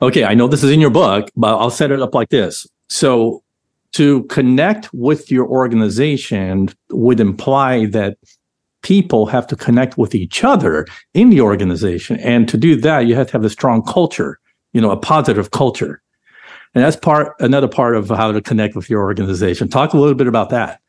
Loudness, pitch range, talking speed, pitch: -14 LUFS, 110-140 Hz, 195 wpm, 125 Hz